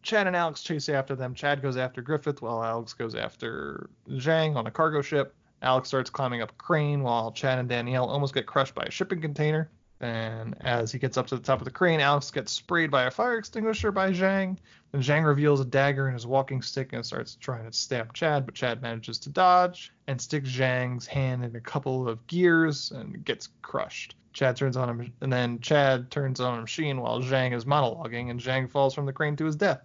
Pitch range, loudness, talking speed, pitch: 125-150 Hz, -27 LUFS, 225 wpm, 135 Hz